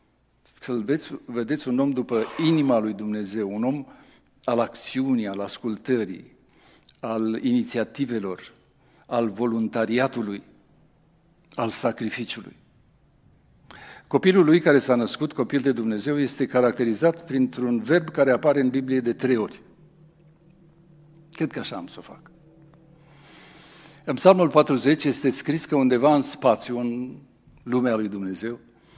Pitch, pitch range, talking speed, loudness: 135 Hz, 120-160 Hz, 125 wpm, -23 LUFS